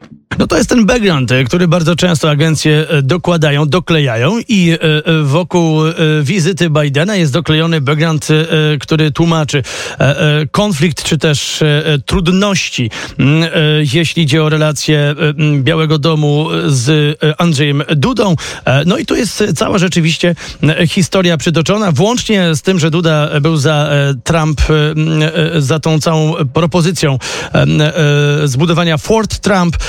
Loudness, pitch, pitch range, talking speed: -11 LUFS, 160 Hz, 150-175 Hz, 110 wpm